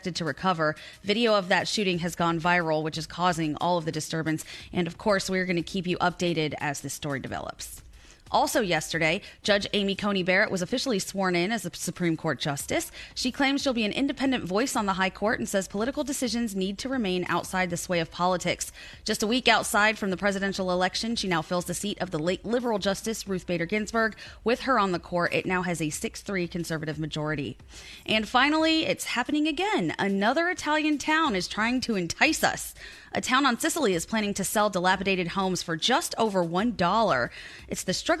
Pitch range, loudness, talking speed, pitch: 175-225 Hz, -26 LUFS, 205 wpm, 190 Hz